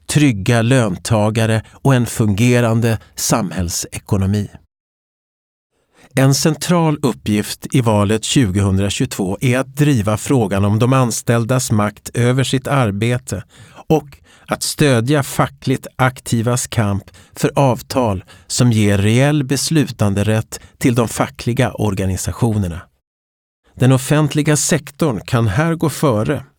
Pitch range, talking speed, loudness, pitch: 105-135 Hz, 105 wpm, -16 LUFS, 120 Hz